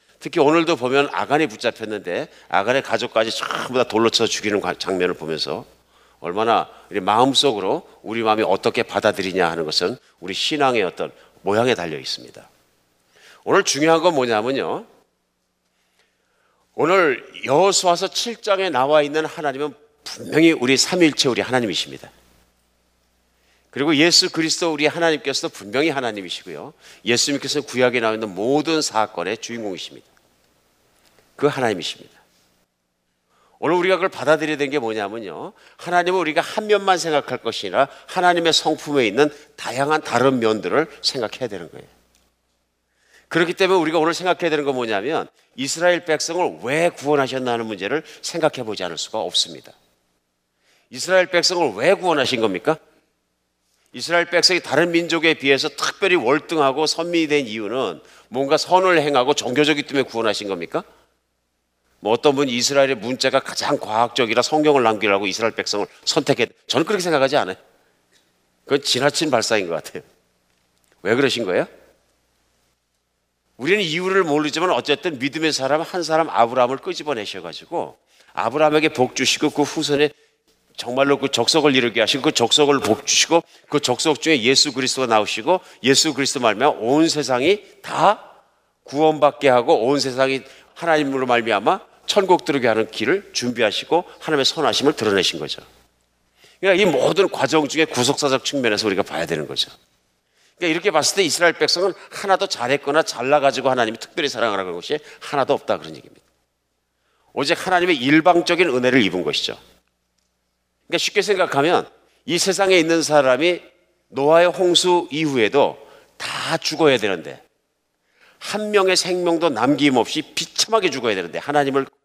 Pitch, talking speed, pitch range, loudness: 145 Hz, 360 characters per minute, 110-165 Hz, -19 LUFS